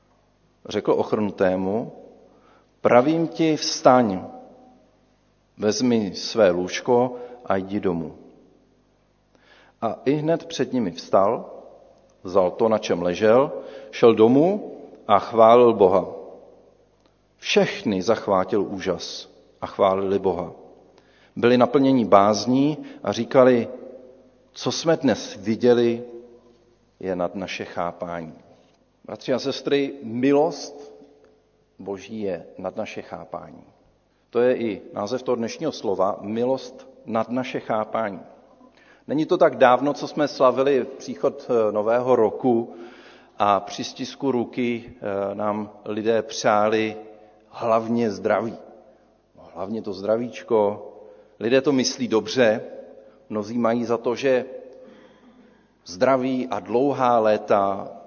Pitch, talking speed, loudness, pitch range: 120 Hz, 105 wpm, -22 LUFS, 105-135 Hz